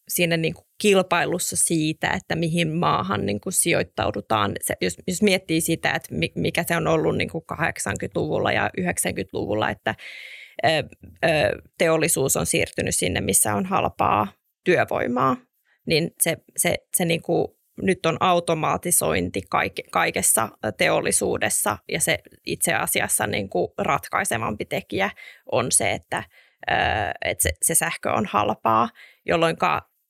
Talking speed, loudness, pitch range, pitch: 135 wpm, -22 LUFS, 160-185 Hz, 170 Hz